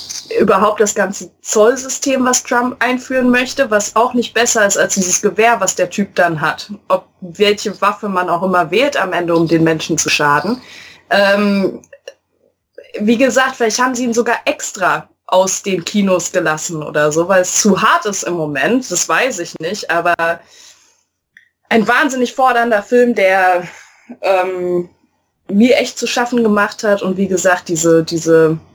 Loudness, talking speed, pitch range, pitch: -14 LUFS, 165 wpm, 180-240 Hz, 200 Hz